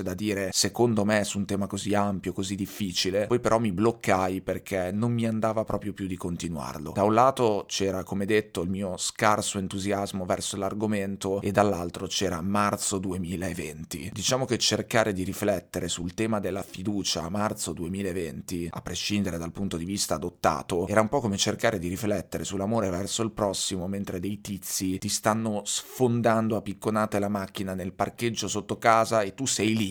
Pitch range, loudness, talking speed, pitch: 95-105 Hz, -27 LUFS, 175 wpm, 100 Hz